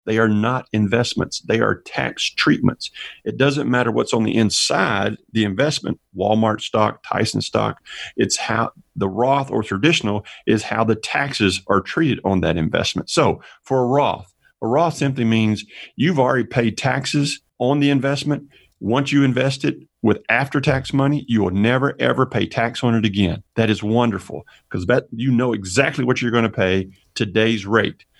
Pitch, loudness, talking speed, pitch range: 120 Hz, -19 LUFS, 175 wpm, 110-135 Hz